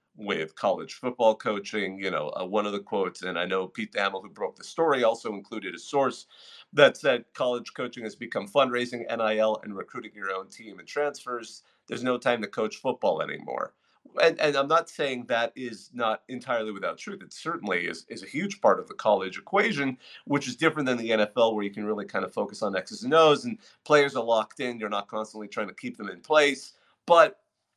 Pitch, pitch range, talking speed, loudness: 115 Hz, 110-135 Hz, 215 wpm, -27 LUFS